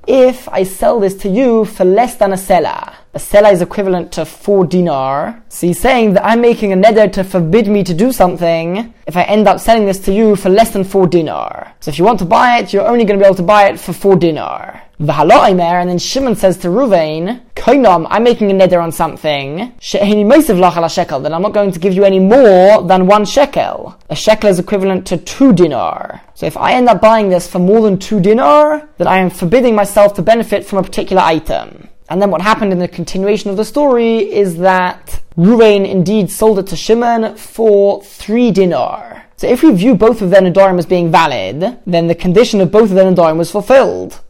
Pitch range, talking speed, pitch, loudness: 180-220 Hz, 220 wpm, 200 Hz, -11 LUFS